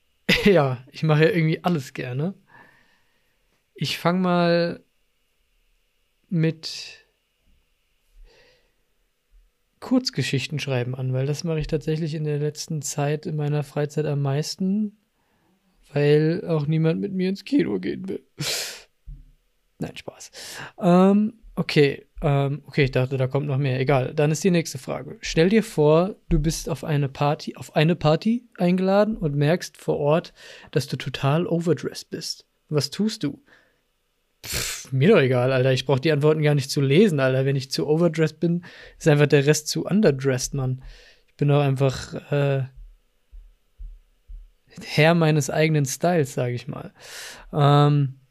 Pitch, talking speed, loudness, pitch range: 150 Hz, 145 wpm, -22 LUFS, 135-170 Hz